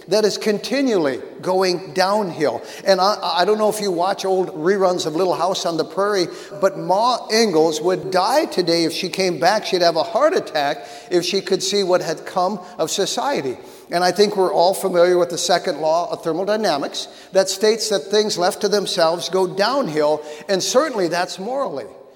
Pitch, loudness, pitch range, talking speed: 185 Hz, -19 LUFS, 175-205 Hz, 190 wpm